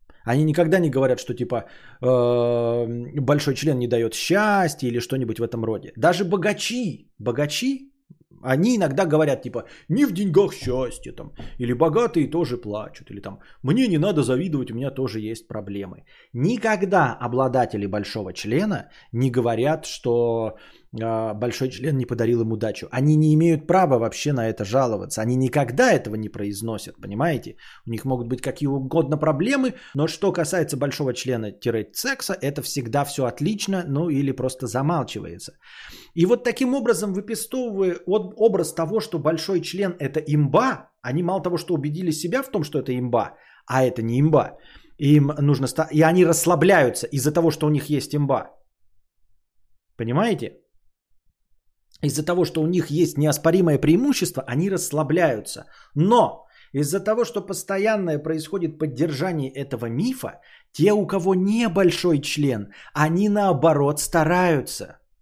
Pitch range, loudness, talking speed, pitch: 120-175 Hz, -22 LUFS, 145 wpm, 145 Hz